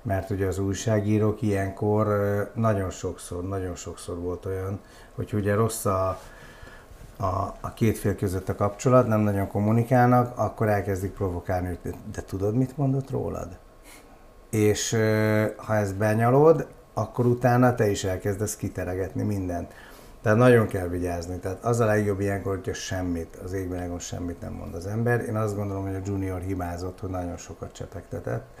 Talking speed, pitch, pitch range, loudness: 155 wpm, 100 Hz, 95-110 Hz, -26 LUFS